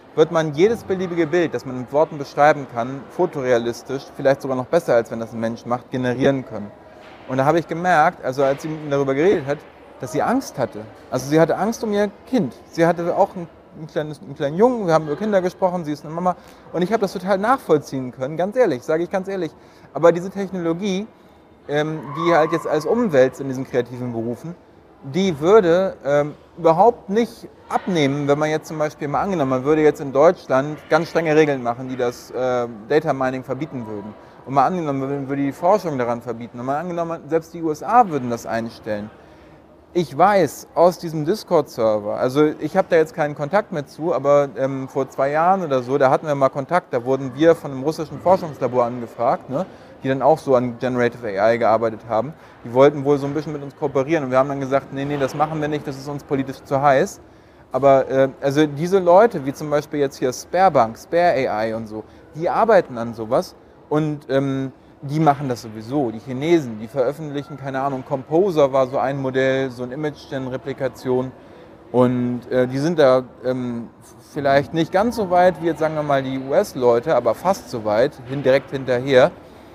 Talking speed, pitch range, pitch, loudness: 205 wpm, 130-165 Hz, 140 Hz, -20 LUFS